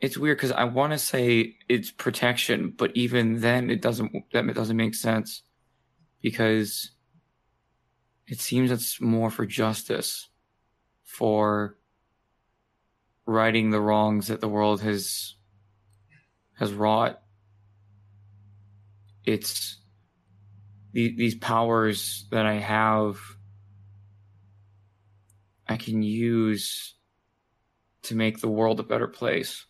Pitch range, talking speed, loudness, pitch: 100-115 Hz, 105 wpm, -25 LUFS, 110 Hz